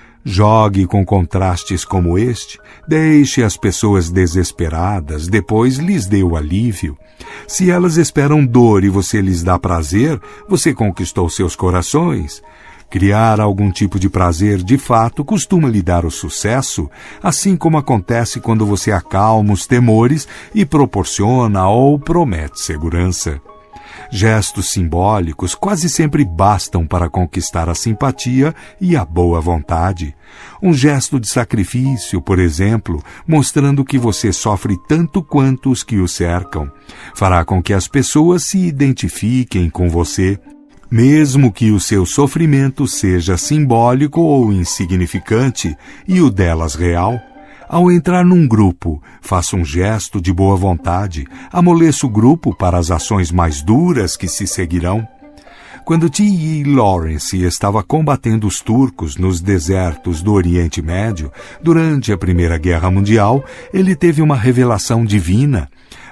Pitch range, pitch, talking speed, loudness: 90-135 Hz, 105 Hz, 130 wpm, -14 LUFS